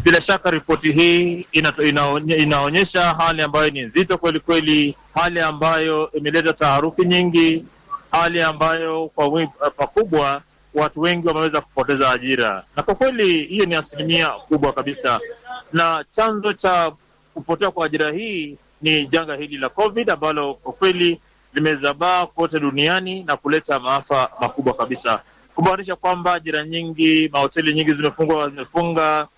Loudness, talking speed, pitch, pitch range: -18 LUFS, 130 wpm, 160 Hz, 150-175 Hz